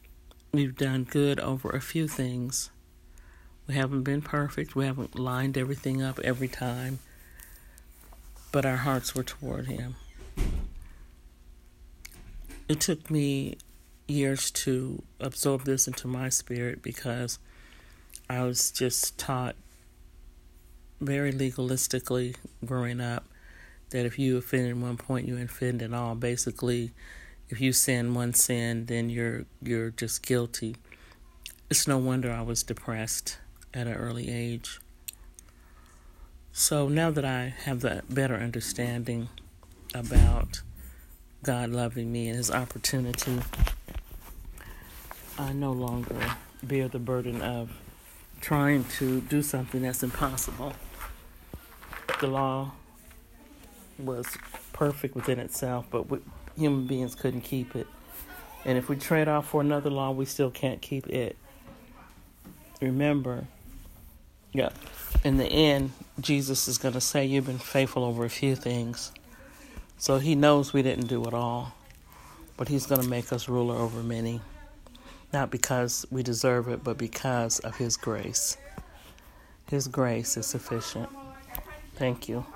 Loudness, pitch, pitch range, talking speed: -29 LUFS, 125 Hz, 115-135 Hz, 130 wpm